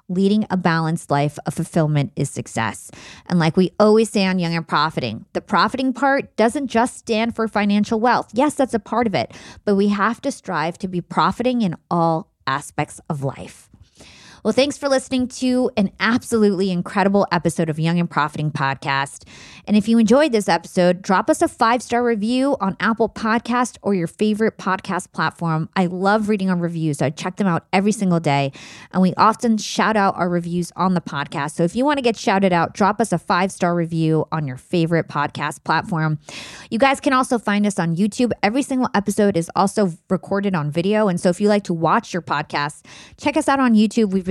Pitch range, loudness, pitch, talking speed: 165-225 Hz, -19 LUFS, 190 Hz, 200 wpm